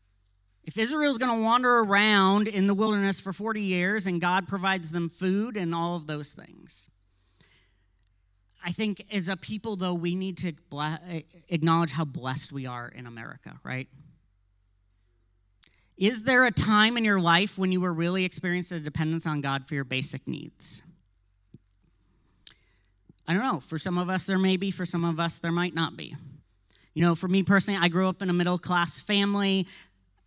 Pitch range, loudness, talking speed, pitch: 130-195 Hz, -26 LUFS, 180 wpm, 170 Hz